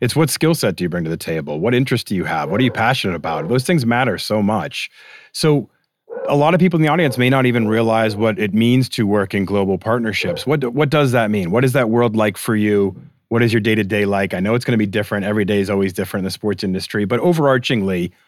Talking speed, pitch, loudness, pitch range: 265 wpm, 110 Hz, -17 LUFS, 100-130 Hz